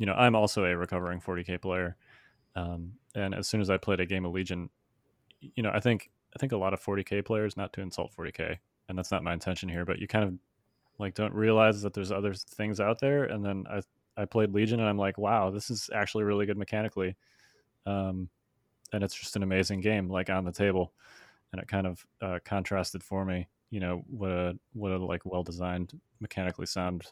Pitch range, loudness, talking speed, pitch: 90-105 Hz, -31 LUFS, 220 wpm, 100 Hz